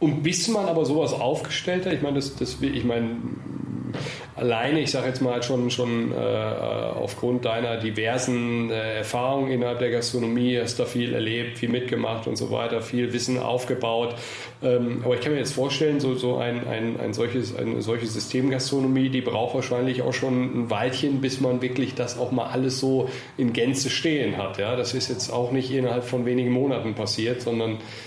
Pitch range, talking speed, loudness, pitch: 120-130 Hz, 190 wpm, -25 LUFS, 125 Hz